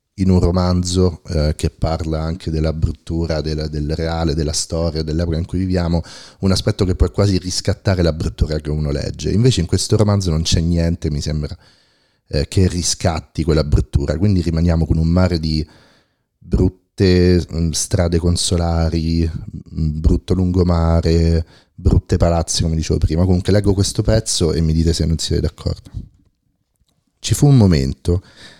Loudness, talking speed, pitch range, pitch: -18 LUFS, 155 wpm, 80-95 Hz, 85 Hz